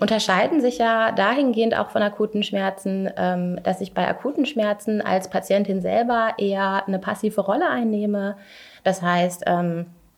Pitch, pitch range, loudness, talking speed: 205 Hz, 190-220 Hz, -22 LUFS, 135 wpm